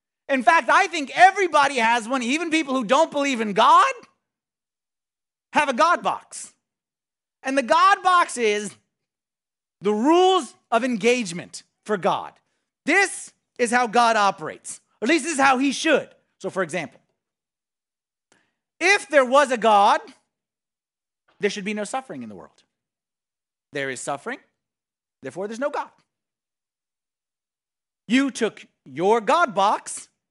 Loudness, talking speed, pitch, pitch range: -20 LUFS, 140 wpm, 260 Hz, 210-305 Hz